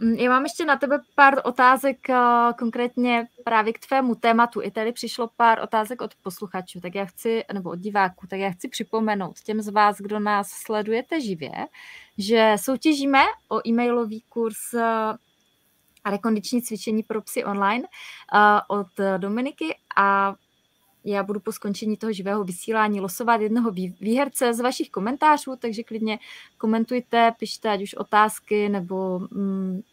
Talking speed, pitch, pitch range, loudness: 140 wpm, 225 Hz, 205-245 Hz, -23 LUFS